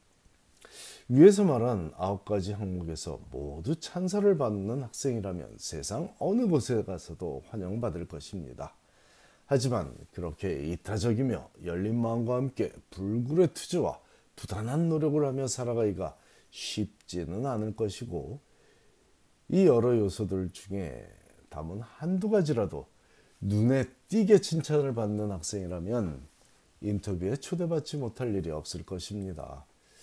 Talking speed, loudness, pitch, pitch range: 270 characters per minute, -30 LUFS, 105 Hz, 90-135 Hz